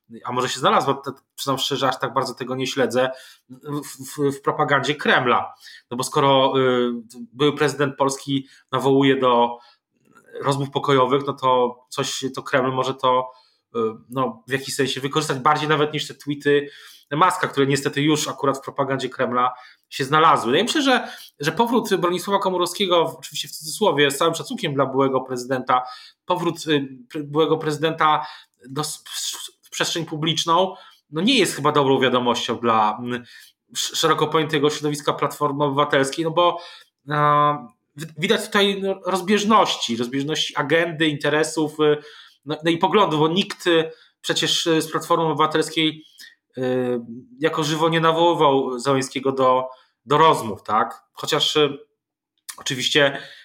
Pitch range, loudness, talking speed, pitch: 130-160 Hz, -21 LUFS, 140 wpm, 145 Hz